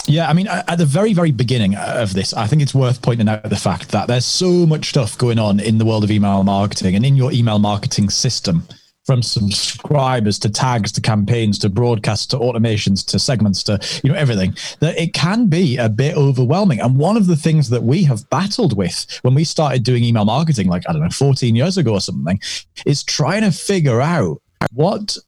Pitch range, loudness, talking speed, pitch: 105-155 Hz, -16 LUFS, 215 wpm, 125 Hz